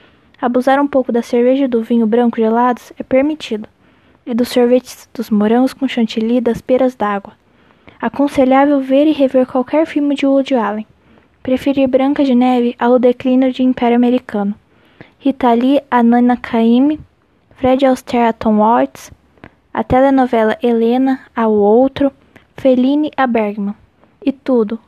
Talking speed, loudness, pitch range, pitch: 140 wpm, -14 LUFS, 235-270 Hz, 255 Hz